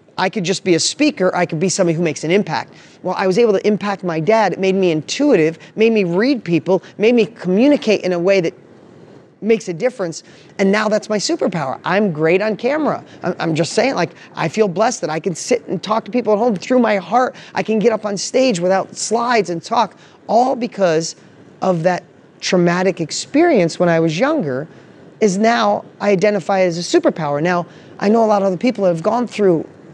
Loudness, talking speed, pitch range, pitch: -17 LUFS, 215 wpm, 180-220 Hz, 195 Hz